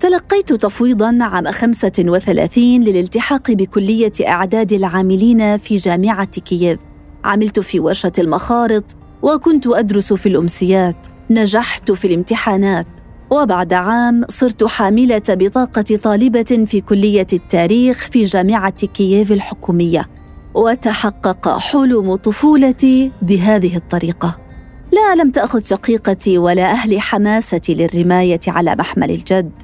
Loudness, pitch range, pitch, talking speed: -14 LUFS, 185-230 Hz, 210 Hz, 105 wpm